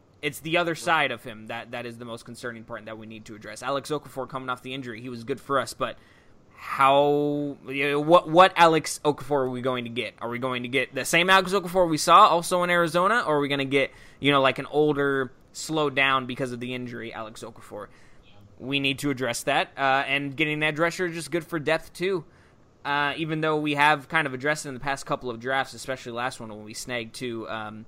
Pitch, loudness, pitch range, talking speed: 135 Hz, -24 LUFS, 120-150 Hz, 245 wpm